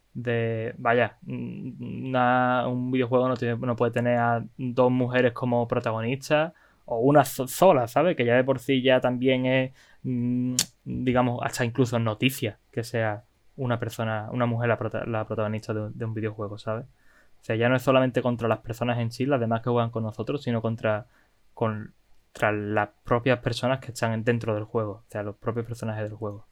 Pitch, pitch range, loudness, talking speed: 120 Hz, 110-125 Hz, -26 LUFS, 180 wpm